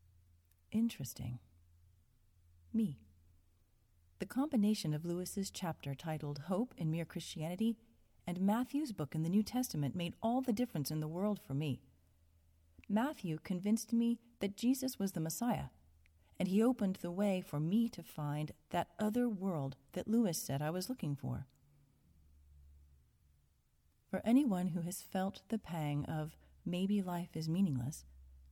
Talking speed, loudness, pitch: 140 wpm, -38 LUFS, 160 Hz